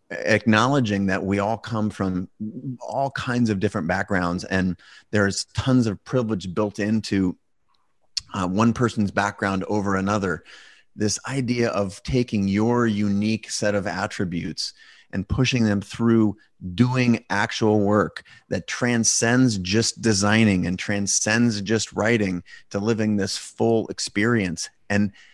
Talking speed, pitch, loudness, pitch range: 130 wpm, 105 Hz, -23 LUFS, 100-115 Hz